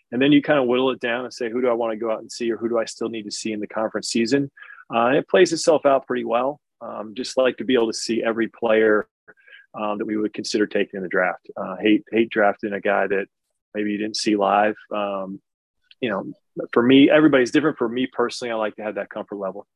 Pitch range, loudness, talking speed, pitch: 105-125 Hz, -21 LUFS, 265 wpm, 115 Hz